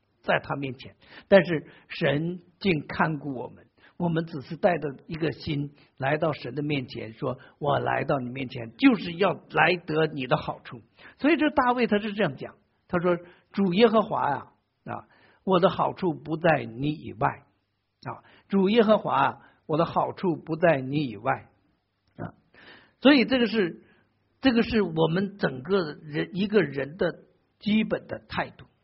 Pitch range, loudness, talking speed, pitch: 140-200 Hz, -26 LUFS, 230 characters per minute, 165 Hz